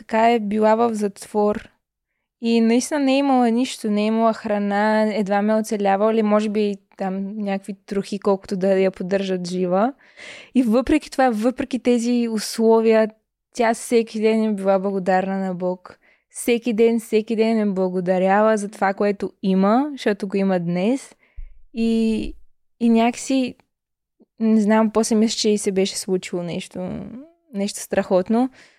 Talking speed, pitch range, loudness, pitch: 150 wpm, 195-230 Hz, -20 LUFS, 215 Hz